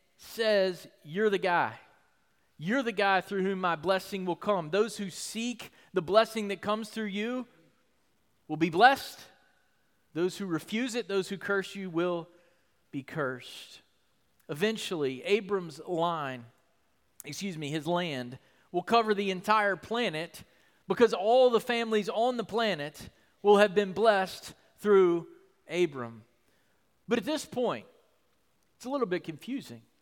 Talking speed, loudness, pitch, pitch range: 140 wpm, -29 LUFS, 195 Hz, 170-220 Hz